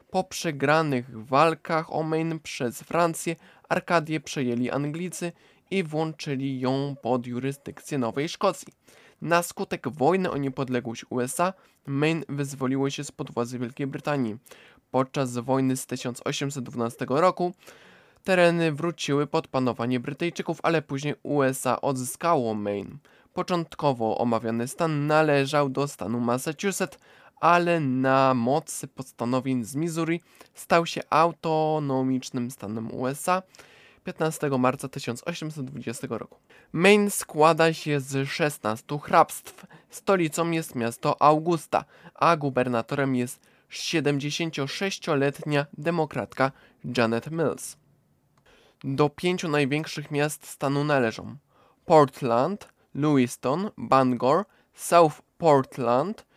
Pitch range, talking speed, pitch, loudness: 130-165 Hz, 100 wpm, 145 Hz, -26 LUFS